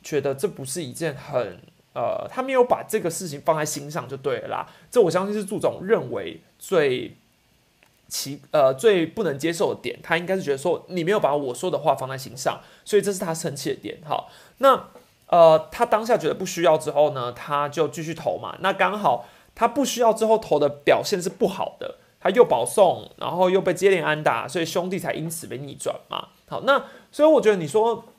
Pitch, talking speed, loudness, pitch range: 185 Hz, 300 characters per minute, -23 LUFS, 160-225 Hz